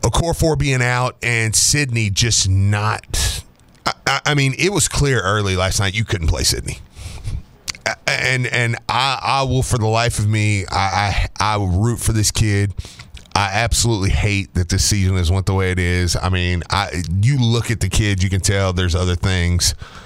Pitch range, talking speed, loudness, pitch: 95-115 Hz, 195 wpm, -17 LUFS, 105 Hz